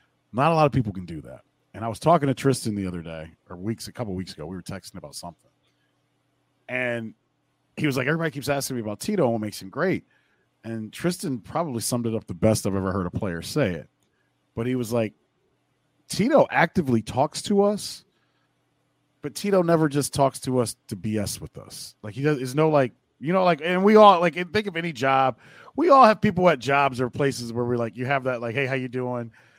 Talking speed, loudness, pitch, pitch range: 235 wpm, -23 LUFS, 130 Hz, 110-155 Hz